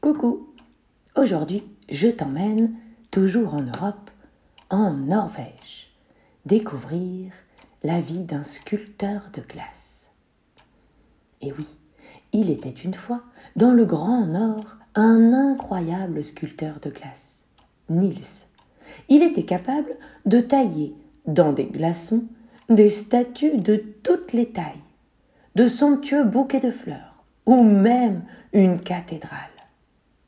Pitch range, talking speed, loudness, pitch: 170-235 Hz, 110 wpm, -21 LUFS, 210 Hz